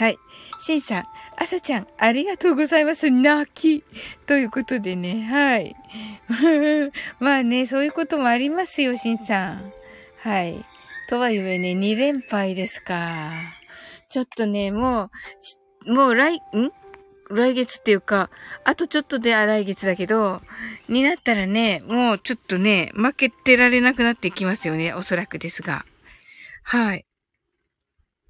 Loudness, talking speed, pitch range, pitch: -21 LUFS, 280 characters per minute, 195-280 Hz, 235 Hz